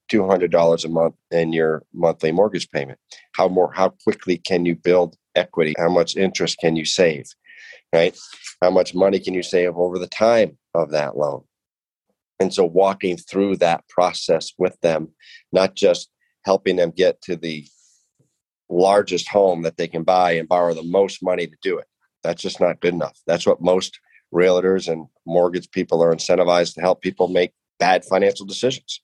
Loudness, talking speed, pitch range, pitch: -19 LUFS, 175 wpm, 85-95 Hz, 90 Hz